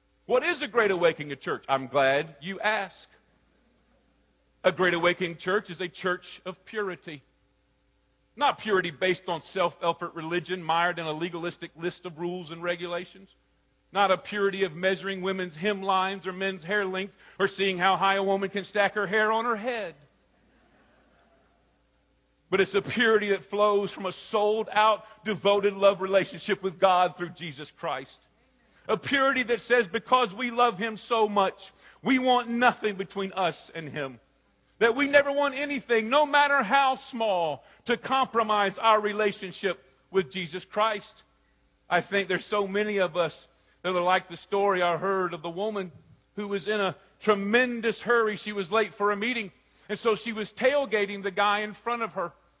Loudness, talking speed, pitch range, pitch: -27 LUFS, 170 wpm, 180-220 Hz, 195 Hz